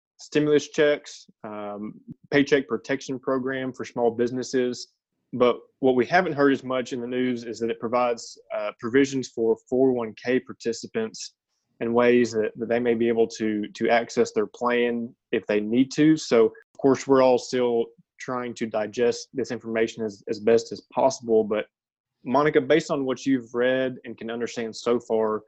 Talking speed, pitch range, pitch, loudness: 170 wpm, 115-135 Hz, 120 Hz, -24 LUFS